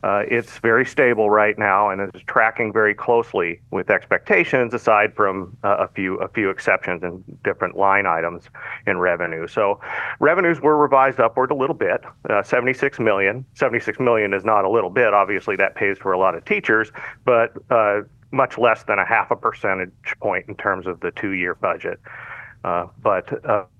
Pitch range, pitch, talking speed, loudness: 95-120 Hz, 105 Hz, 180 wpm, -19 LUFS